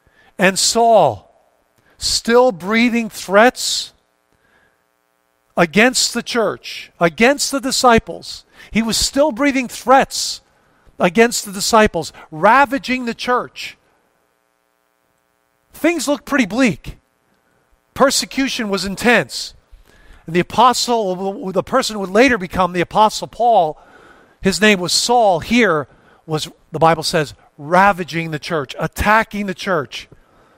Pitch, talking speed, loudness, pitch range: 195 Hz, 110 wpm, -16 LUFS, 155-240 Hz